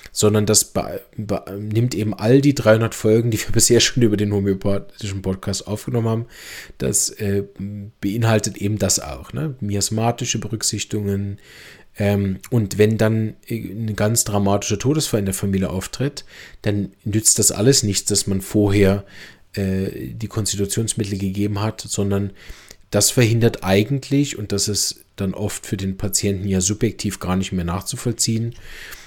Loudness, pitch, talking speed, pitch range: -20 LUFS, 105 Hz, 150 wpm, 100-115 Hz